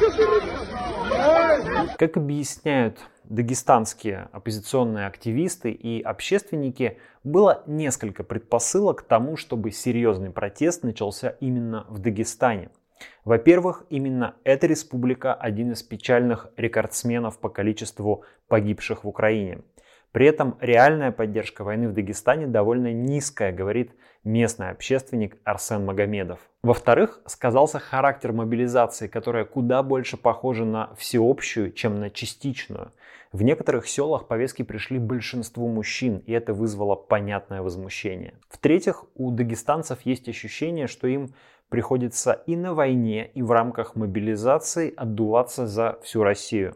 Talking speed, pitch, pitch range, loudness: 115 wpm, 115 Hz, 110-130 Hz, -24 LUFS